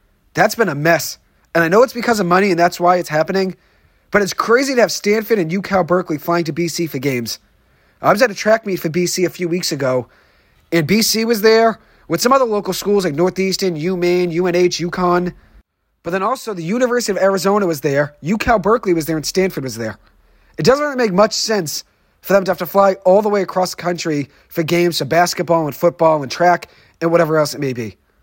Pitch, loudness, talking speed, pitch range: 180 Hz, -16 LUFS, 225 wpm, 165-200 Hz